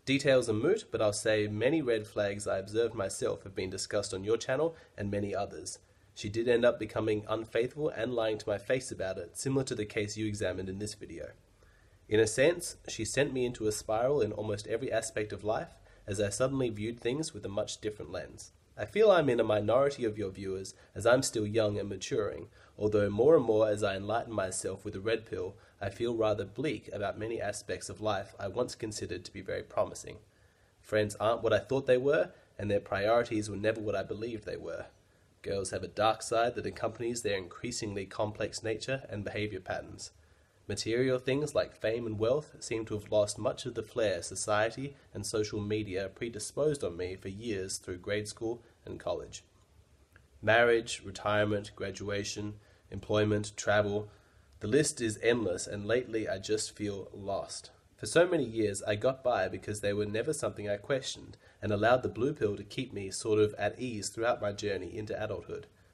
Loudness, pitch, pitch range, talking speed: -32 LUFS, 105 Hz, 100-115 Hz, 195 wpm